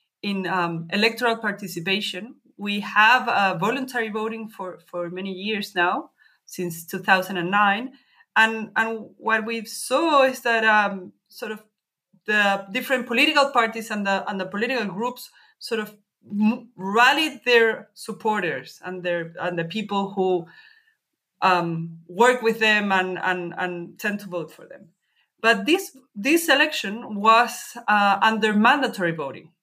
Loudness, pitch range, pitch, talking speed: -22 LUFS, 190-235 Hz, 210 Hz, 140 wpm